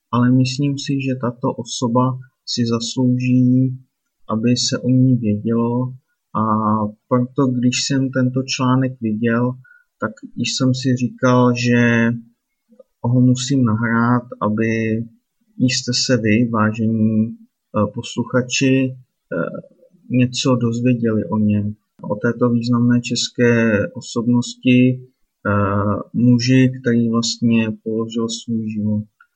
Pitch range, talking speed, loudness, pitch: 115-130 Hz, 100 wpm, -18 LUFS, 120 Hz